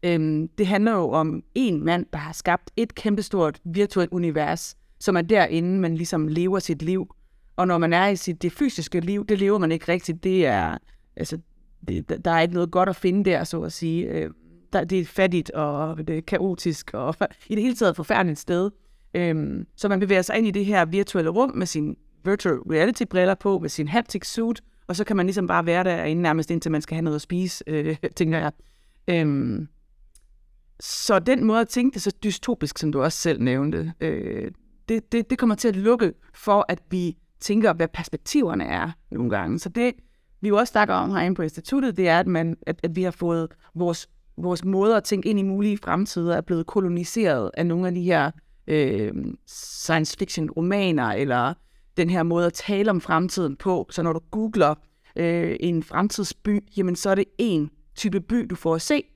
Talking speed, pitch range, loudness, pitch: 200 wpm, 160-200 Hz, -24 LUFS, 175 Hz